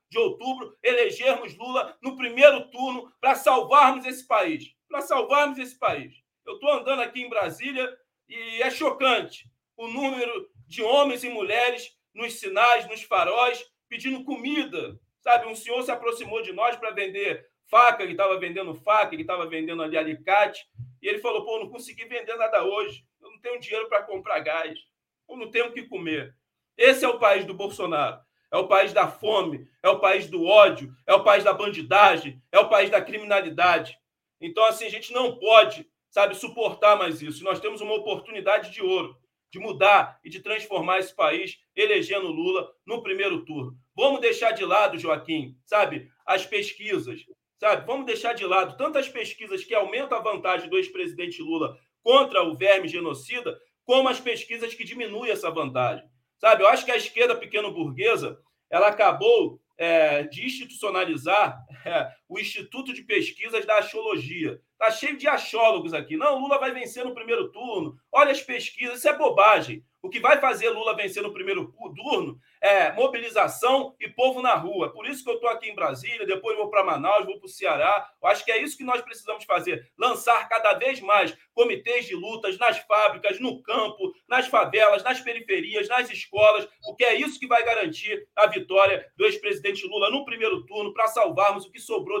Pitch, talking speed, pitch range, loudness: 245 Hz, 180 wpm, 210-310 Hz, -23 LUFS